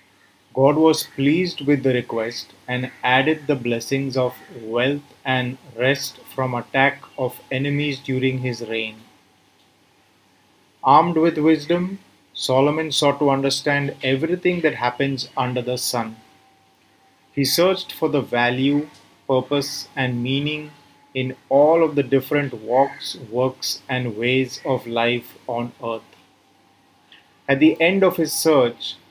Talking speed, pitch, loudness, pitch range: 125 wpm, 135 Hz, -21 LUFS, 125-145 Hz